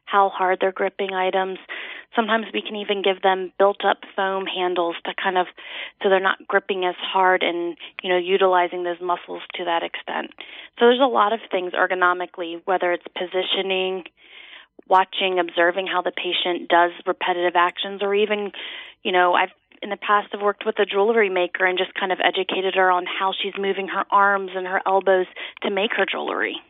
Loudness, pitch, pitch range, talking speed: -21 LUFS, 190 Hz, 180-200 Hz, 185 wpm